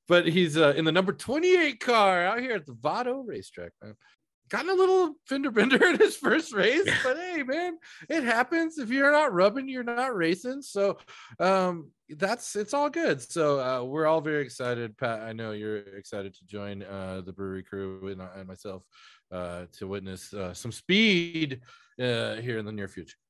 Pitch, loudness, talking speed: 165 Hz, -26 LUFS, 195 wpm